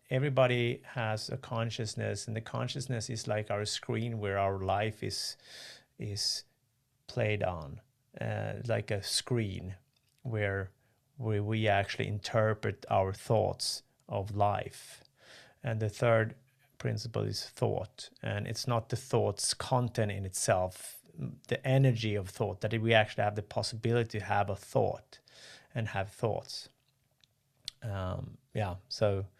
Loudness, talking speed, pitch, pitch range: -33 LUFS, 135 wpm, 110 Hz, 105-125 Hz